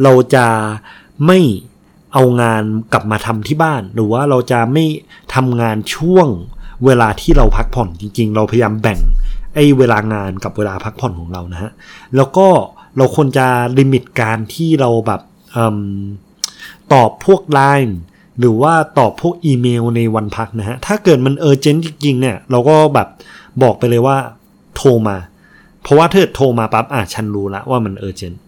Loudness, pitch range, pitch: -13 LUFS, 110-140 Hz, 120 Hz